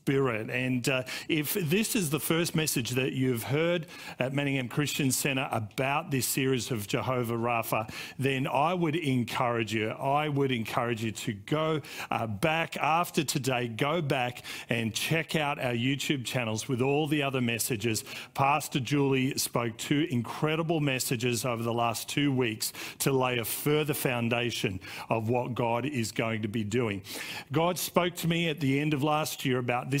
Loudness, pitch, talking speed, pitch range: -29 LUFS, 135 Hz, 170 wpm, 120-150 Hz